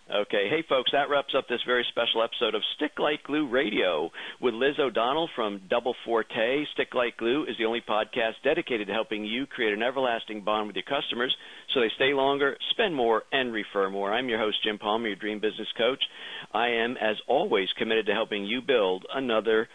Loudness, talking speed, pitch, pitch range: -27 LUFS, 205 wpm, 115 Hz, 105-135 Hz